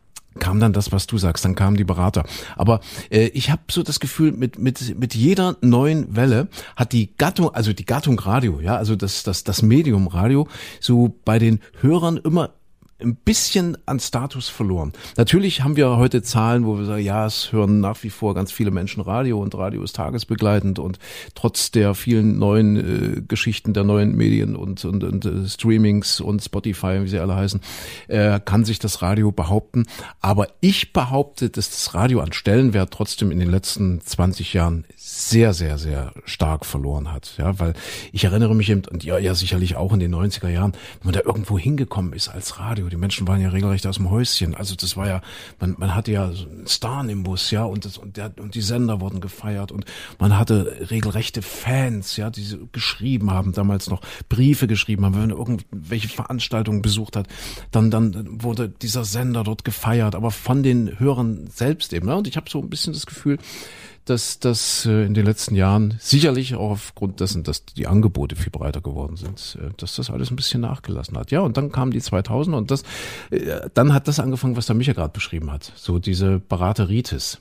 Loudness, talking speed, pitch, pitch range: -20 LUFS, 200 wpm, 105 Hz, 95-120 Hz